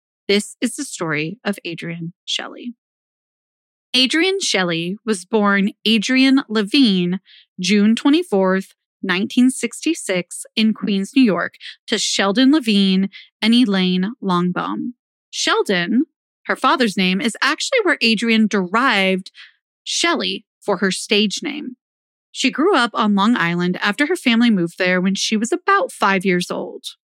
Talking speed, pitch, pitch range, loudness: 130 wpm, 220 Hz, 195-260 Hz, -18 LUFS